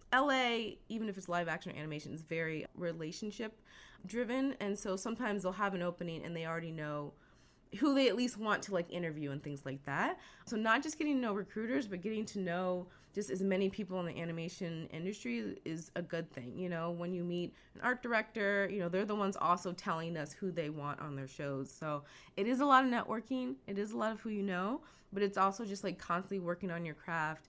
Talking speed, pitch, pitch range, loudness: 230 wpm, 185 Hz, 165-220 Hz, -37 LUFS